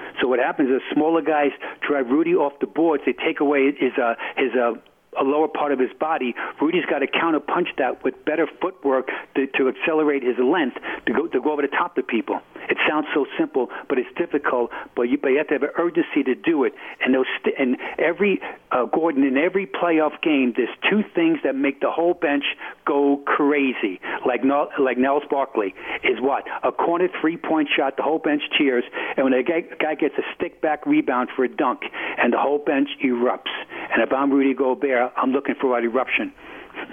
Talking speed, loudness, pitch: 210 wpm, -21 LUFS, 150 Hz